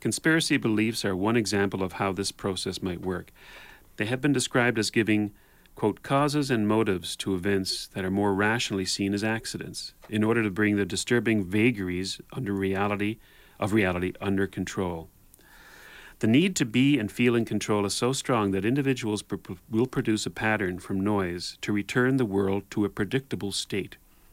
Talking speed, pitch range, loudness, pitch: 175 wpm, 95-115 Hz, -27 LUFS, 105 Hz